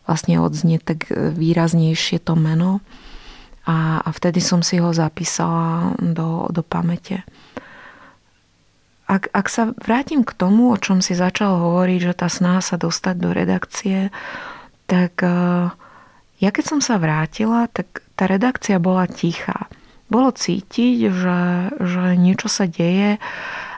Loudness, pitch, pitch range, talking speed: -19 LUFS, 180 Hz, 170-205 Hz, 130 wpm